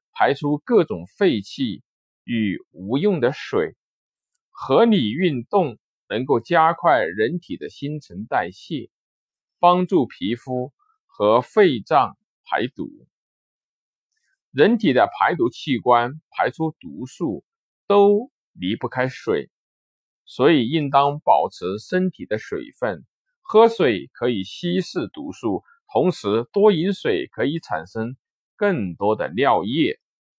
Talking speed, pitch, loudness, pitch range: 165 characters per minute, 160 Hz, -21 LUFS, 125-205 Hz